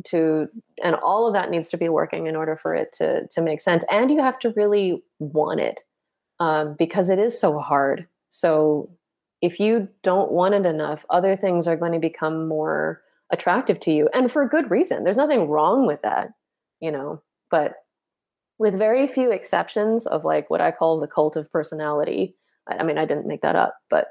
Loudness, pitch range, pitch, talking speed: -22 LUFS, 155-210 Hz, 175 Hz, 200 wpm